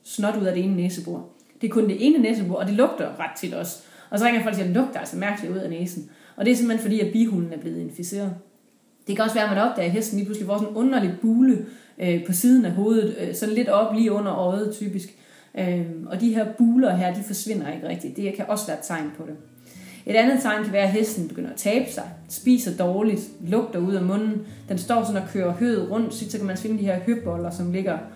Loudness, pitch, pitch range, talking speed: -23 LUFS, 210 Hz, 185-225 Hz, 260 wpm